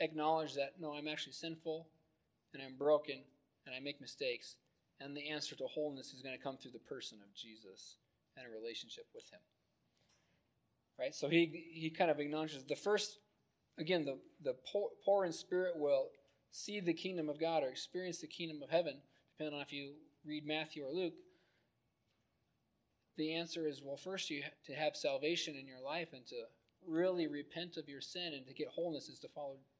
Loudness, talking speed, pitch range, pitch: -41 LUFS, 190 wpm, 140-170 Hz, 155 Hz